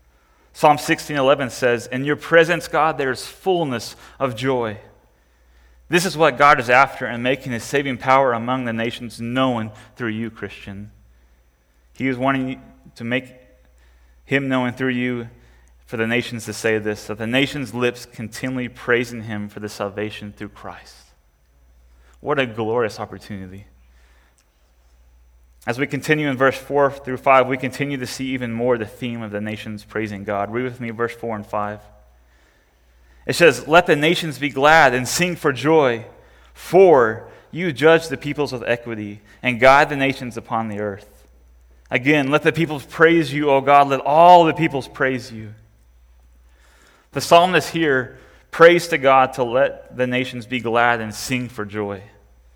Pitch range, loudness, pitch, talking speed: 100-135 Hz, -19 LUFS, 120 Hz, 165 wpm